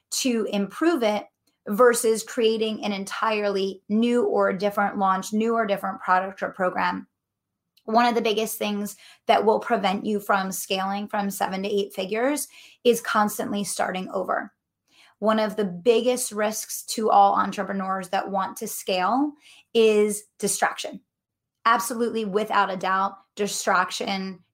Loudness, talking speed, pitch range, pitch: -24 LUFS, 135 wpm, 195-225 Hz, 210 Hz